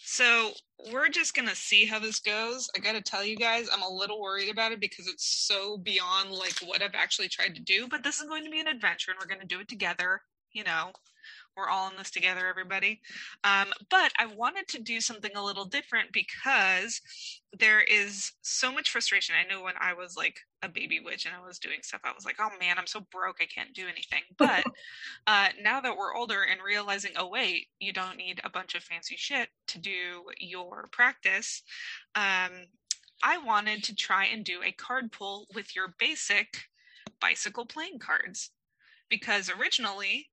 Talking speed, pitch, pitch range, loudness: 205 wpm, 205 Hz, 190-235 Hz, -28 LUFS